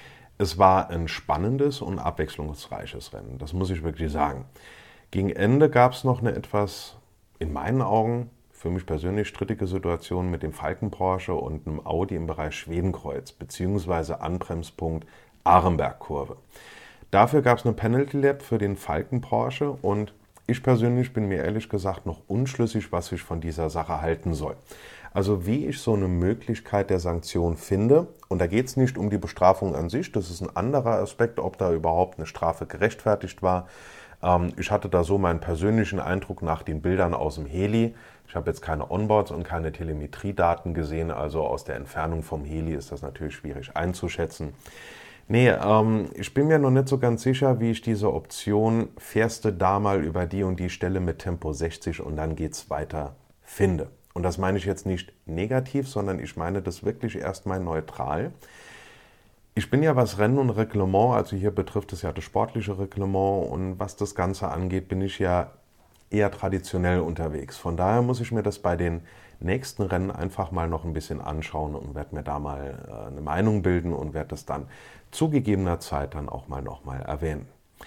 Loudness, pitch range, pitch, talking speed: -26 LUFS, 80-105 Hz, 95 Hz, 180 wpm